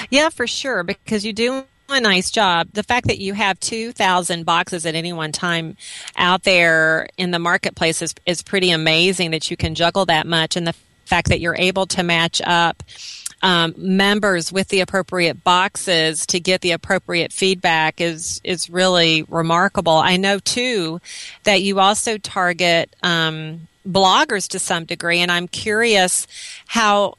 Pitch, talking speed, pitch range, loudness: 180 Hz, 170 wpm, 170-195 Hz, -17 LUFS